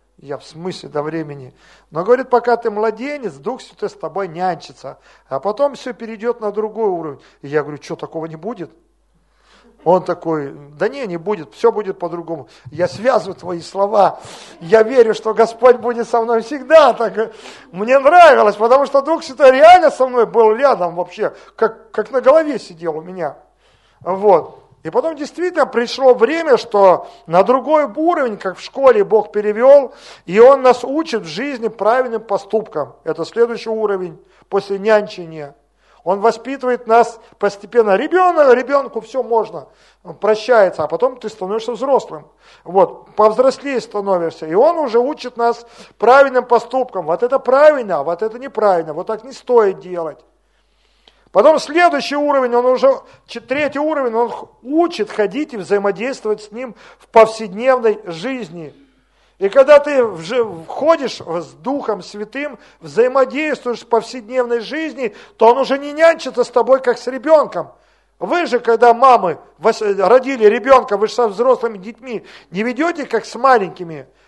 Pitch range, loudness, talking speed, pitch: 195-265 Hz, -15 LUFS, 150 wpm, 230 Hz